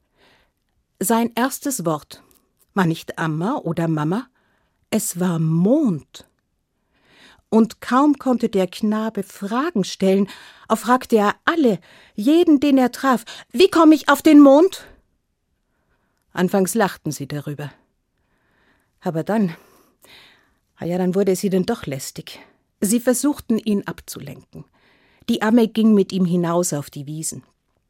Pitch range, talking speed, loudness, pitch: 170-245 Hz, 125 wpm, -19 LUFS, 205 Hz